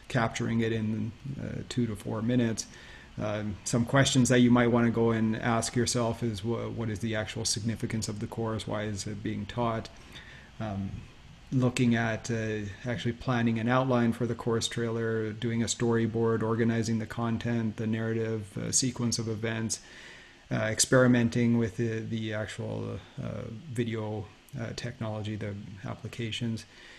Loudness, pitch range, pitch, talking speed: -30 LUFS, 110-120 Hz, 115 Hz, 160 wpm